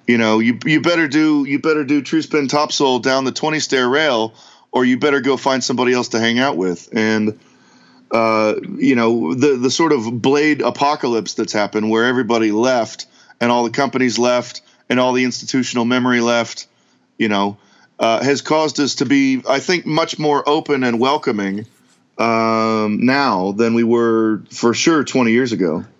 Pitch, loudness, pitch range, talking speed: 125 Hz, -16 LUFS, 115-140 Hz, 180 wpm